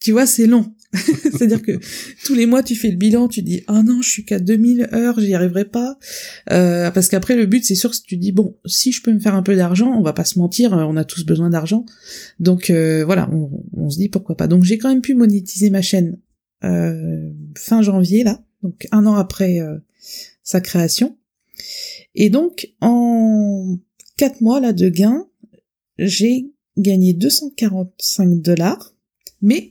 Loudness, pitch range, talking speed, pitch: -16 LUFS, 185-235 Hz, 195 wpm, 210 Hz